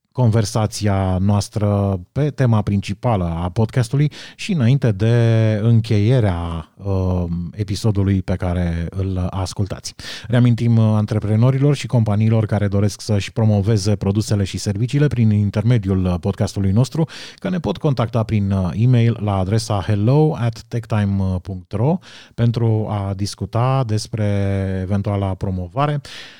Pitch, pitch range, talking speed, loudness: 105 Hz, 100-120 Hz, 110 wpm, -19 LUFS